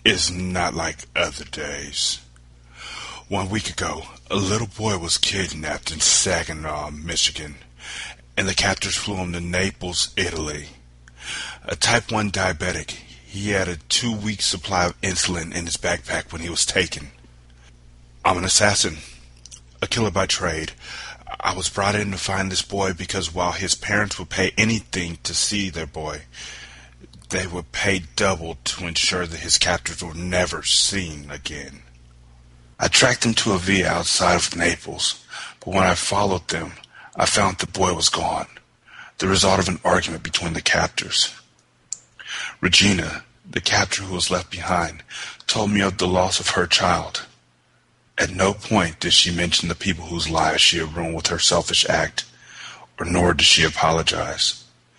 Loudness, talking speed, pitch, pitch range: -20 LUFS, 160 wpm, 90 Hz, 75-95 Hz